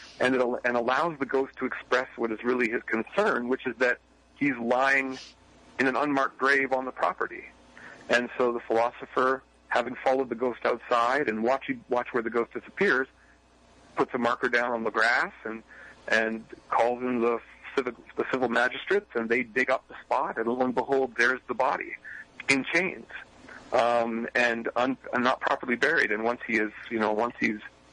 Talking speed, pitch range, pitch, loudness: 185 wpm, 115-130 Hz, 125 Hz, -27 LUFS